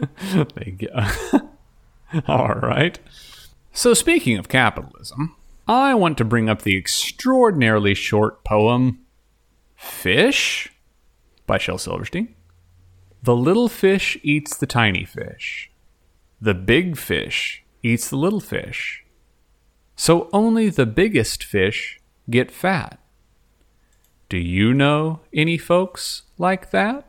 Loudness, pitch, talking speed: -19 LUFS, 120 Hz, 115 wpm